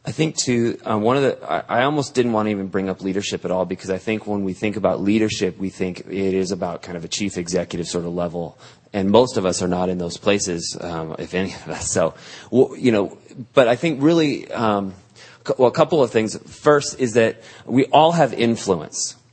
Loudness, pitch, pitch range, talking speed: -20 LUFS, 100 Hz, 90-120 Hz, 230 wpm